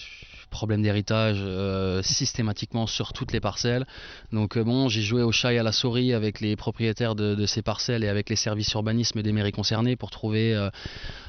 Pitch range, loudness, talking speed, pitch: 105-115 Hz, -25 LUFS, 195 wpm, 110 Hz